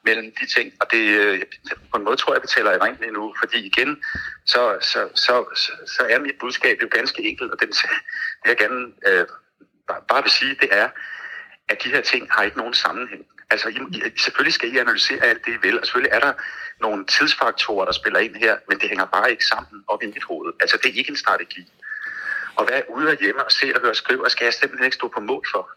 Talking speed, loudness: 240 wpm, -19 LUFS